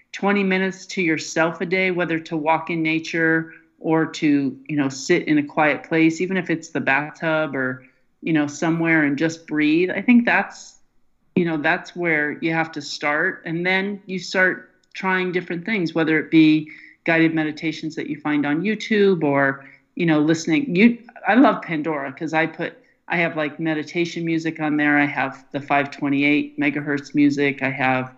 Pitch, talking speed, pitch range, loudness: 160 Hz, 185 wpm, 145-175 Hz, -20 LUFS